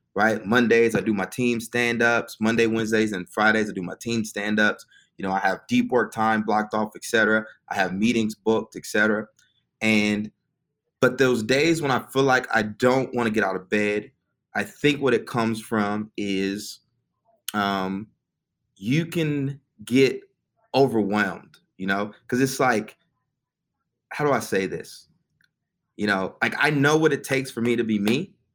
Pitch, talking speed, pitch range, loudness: 115 Hz, 170 wpm, 105-130 Hz, -23 LUFS